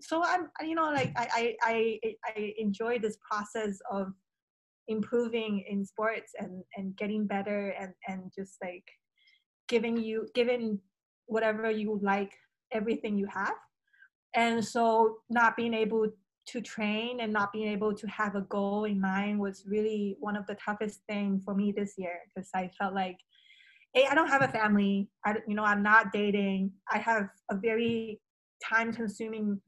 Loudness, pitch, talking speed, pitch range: -31 LUFS, 215 Hz, 165 wpm, 200-230 Hz